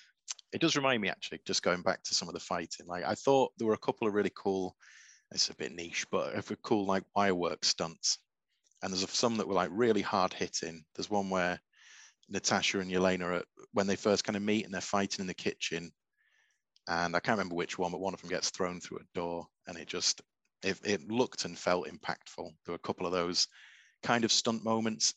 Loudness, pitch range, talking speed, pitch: -33 LUFS, 85-105 Hz, 225 wpm, 95 Hz